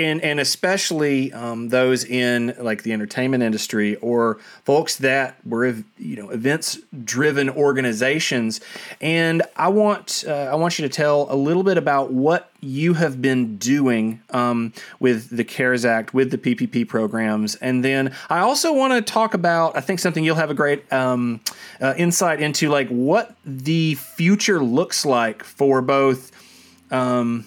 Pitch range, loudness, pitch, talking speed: 120-160 Hz, -20 LUFS, 135 Hz, 160 wpm